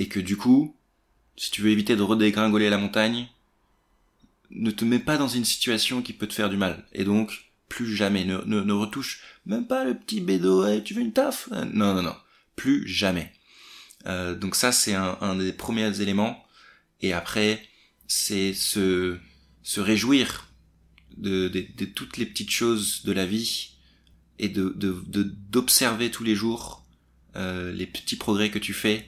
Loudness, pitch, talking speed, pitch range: -25 LUFS, 105 Hz, 180 wpm, 95-115 Hz